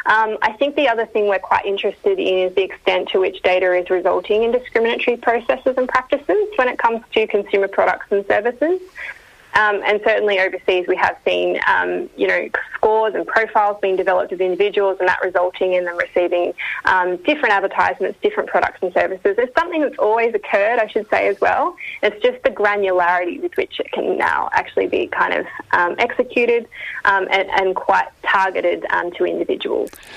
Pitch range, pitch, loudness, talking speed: 190-305 Hz, 220 Hz, -18 LUFS, 185 wpm